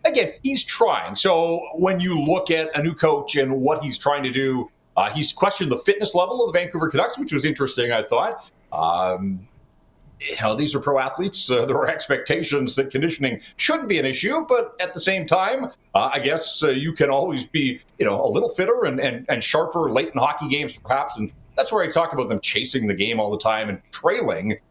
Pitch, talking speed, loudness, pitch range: 160 Hz, 220 wpm, -22 LUFS, 135-190 Hz